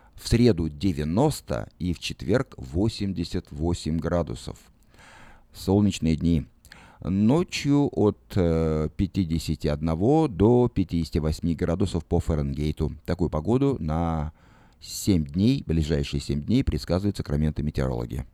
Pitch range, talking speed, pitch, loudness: 75-100 Hz, 95 wpm, 85 Hz, -25 LUFS